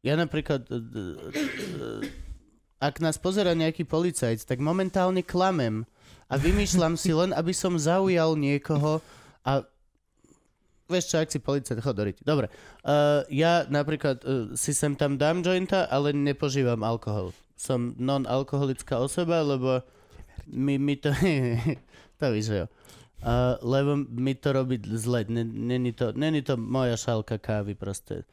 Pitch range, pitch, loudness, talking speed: 120-160 Hz, 140 Hz, -27 LUFS, 125 wpm